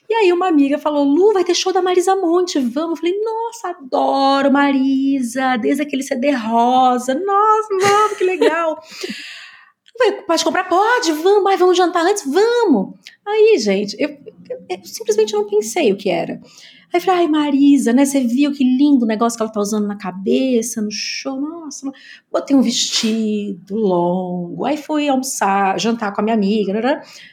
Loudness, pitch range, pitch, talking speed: -16 LUFS, 245-370 Hz, 290 Hz, 180 wpm